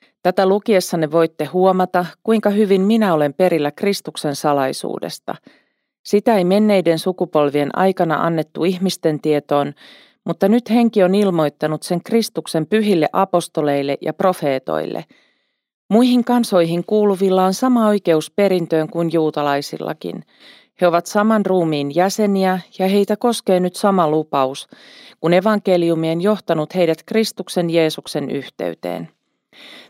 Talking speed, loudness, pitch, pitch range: 115 wpm, -17 LUFS, 180 Hz, 155-205 Hz